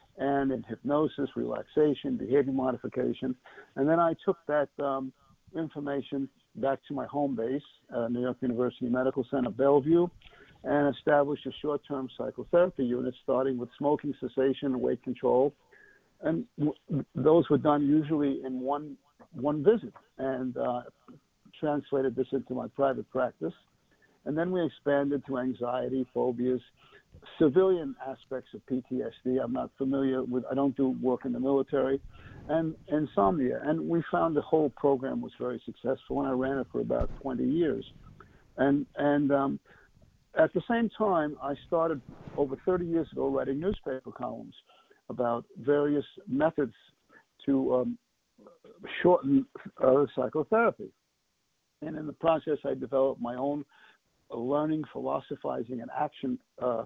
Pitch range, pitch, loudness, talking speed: 130-150 Hz, 140 Hz, -30 LUFS, 145 wpm